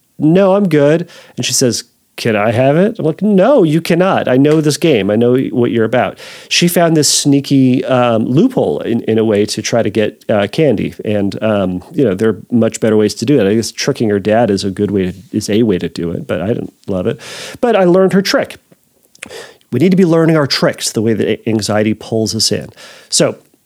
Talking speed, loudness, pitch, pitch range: 235 wpm, -13 LUFS, 125 Hz, 110-160 Hz